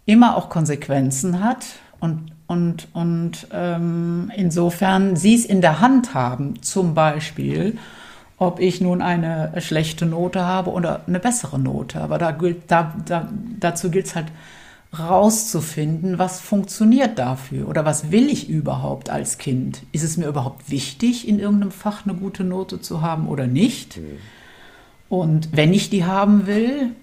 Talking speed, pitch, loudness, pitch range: 155 wpm, 175 Hz, -20 LUFS, 160-195 Hz